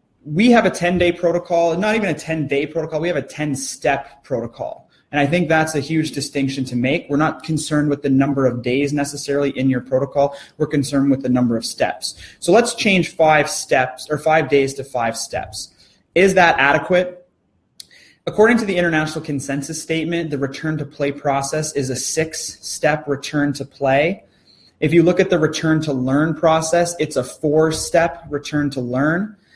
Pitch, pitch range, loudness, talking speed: 150 Hz, 140-165 Hz, -18 LUFS, 190 wpm